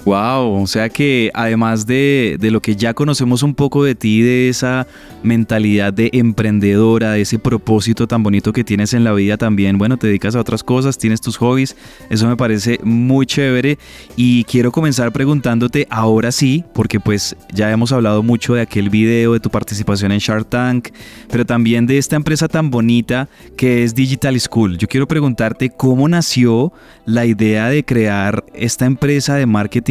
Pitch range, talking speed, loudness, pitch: 110-130 Hz, 180 wpm, -14 LUFS, 120 Hz